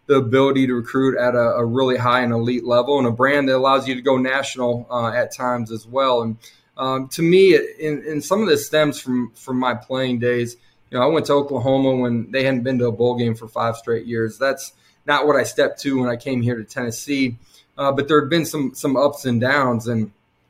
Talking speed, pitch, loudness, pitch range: 245 wpm, 130 Hz, -19 LUFS, 120-135 Hz